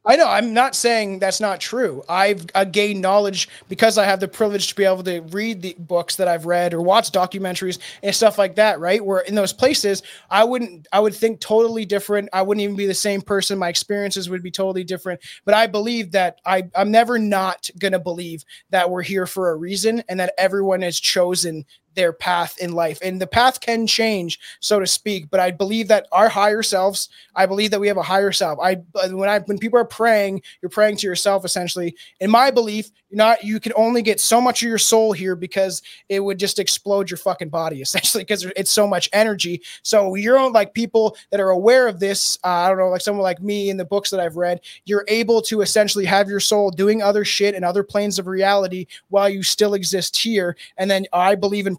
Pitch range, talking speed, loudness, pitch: 185-210 Hz, 230 wpm, -19 LUFS, 195 Hz